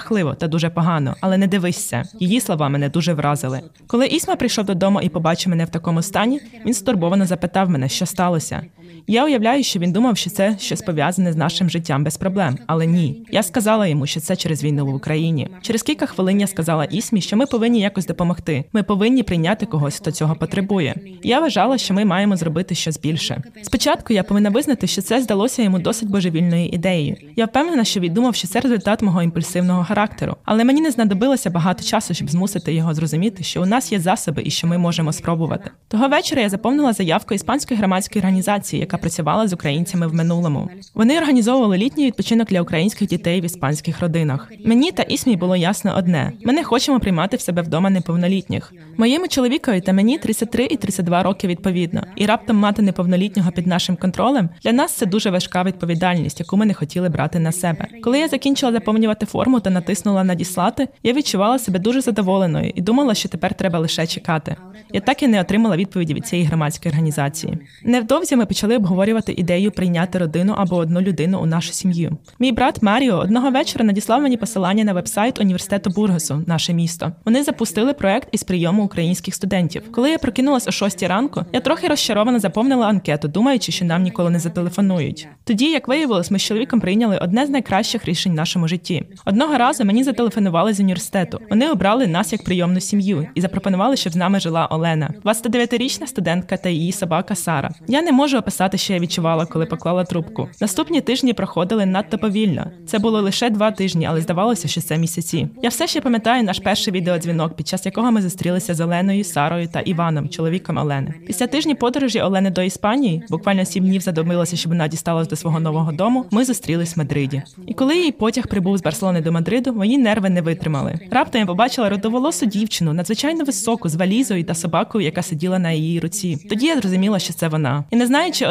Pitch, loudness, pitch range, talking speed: 190 Hz, -18 LUFS, 170-230 Hz, 190 wpm